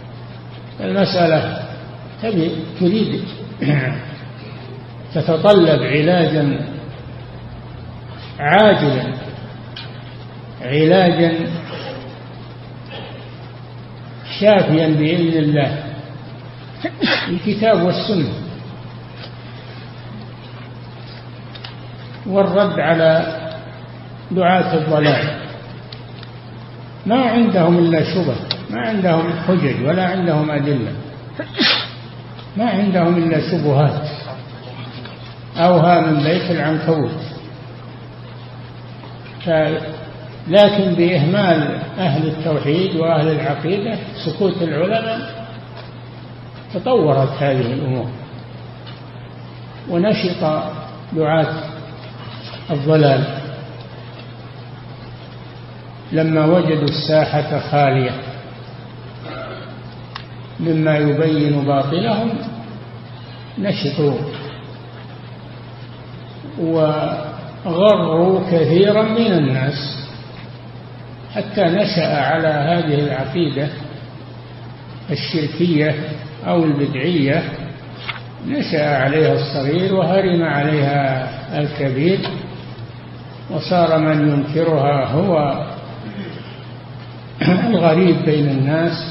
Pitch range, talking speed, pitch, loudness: 125-165 Hz, 55 wpm, 145 Hz, -17 LUFS